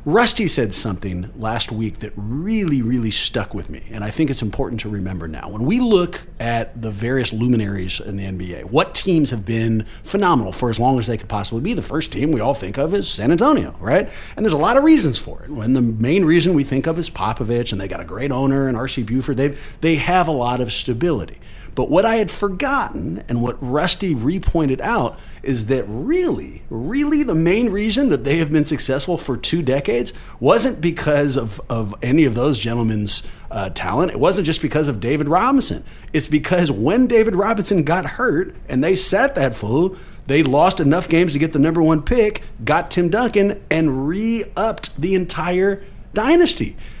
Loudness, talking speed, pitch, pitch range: -19 LUFS, 200 wpm, 140 Hz, 115-180 Hz